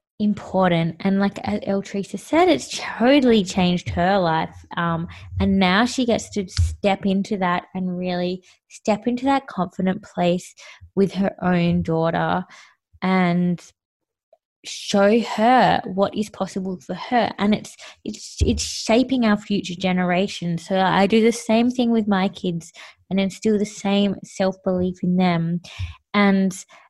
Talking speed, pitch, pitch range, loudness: 145 wpm, 195 Hz, 180-210 Hz, -21 LUFS